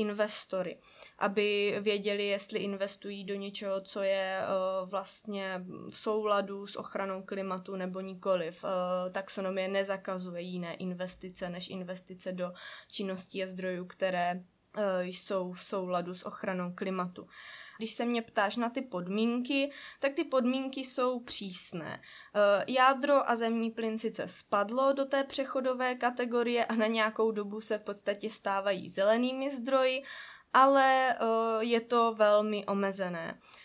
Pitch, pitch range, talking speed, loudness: 205 Hz, 190-230 Hz, 125 wpm, -32 LUFS